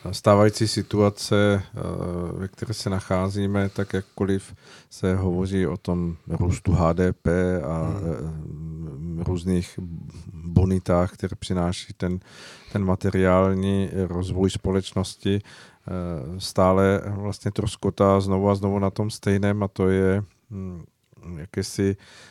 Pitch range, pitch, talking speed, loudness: 90-100 Hz, 95 Hz, 100 wpm, -24 LUFS